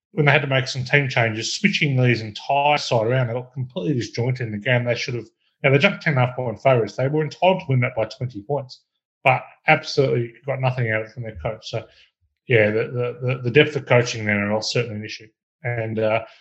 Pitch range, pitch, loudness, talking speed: 115-140 Hz, 125 Hz, -21 LUFS, 245 wpm